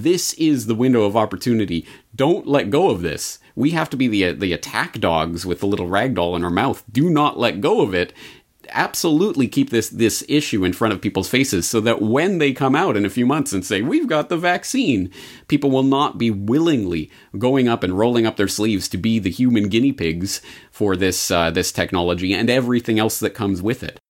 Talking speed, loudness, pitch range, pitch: 220 wpm, -19 LUFS, 95-135 Hz, 115 Hz